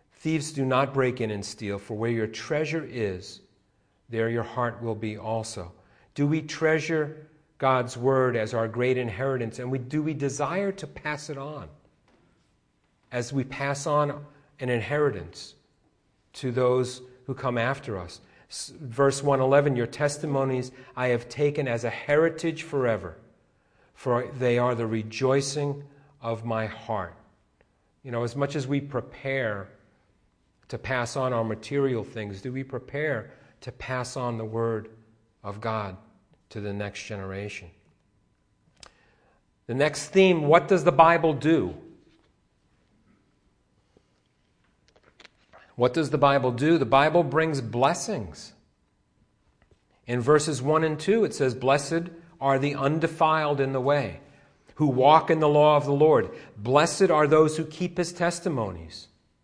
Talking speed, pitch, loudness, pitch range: 140 wpm, 130 Hz, -26 LUFS, 115-150 Hz